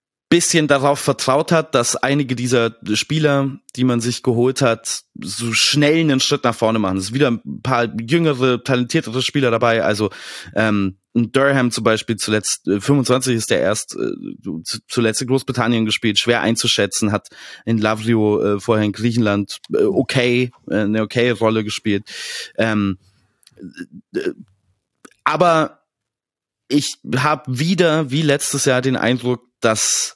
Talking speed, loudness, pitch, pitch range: 140 wpm, -18 LUFS, 120 Hz, 110-135 Hz